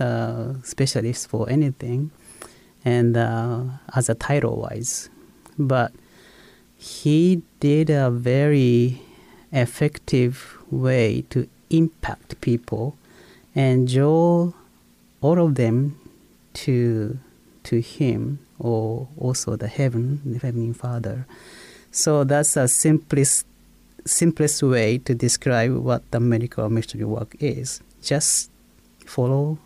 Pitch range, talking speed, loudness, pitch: 115-145 Hz, 100 wpm, -22 LUFS, 125 Hz